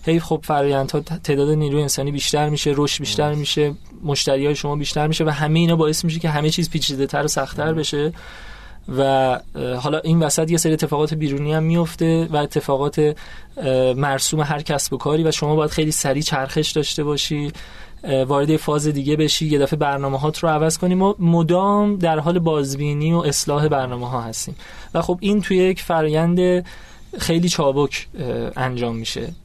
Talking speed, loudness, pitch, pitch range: 175 wpm, -19 LUFS, 150 Hz, 145-160 Hz